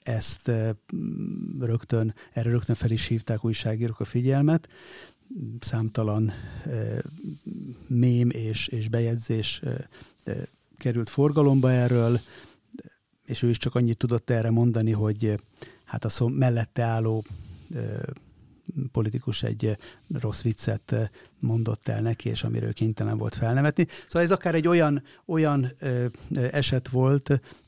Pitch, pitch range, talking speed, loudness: 120 Hz, 115-135 Hz, 115 wpm, -26 LUFS